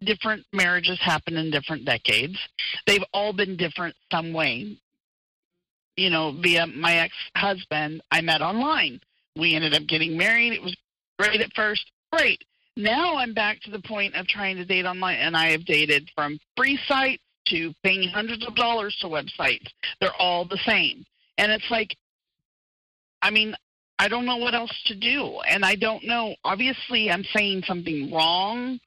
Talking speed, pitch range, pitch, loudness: 170 wpm, 165-220 Hz, 190 Hz, -23 LUFS